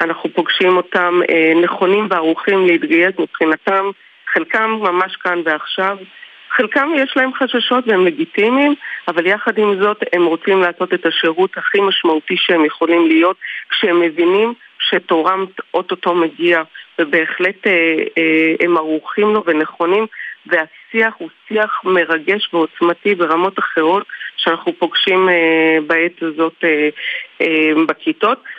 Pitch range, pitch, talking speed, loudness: 165-200 Hz, 175 Hz, 115 wpm, -15 LUFS